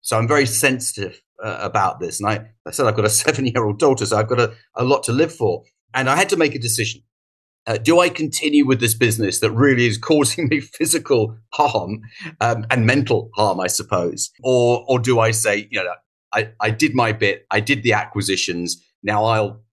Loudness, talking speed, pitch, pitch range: -18 LUFS, 220 wpm, 115 Hz, 110-135 Hz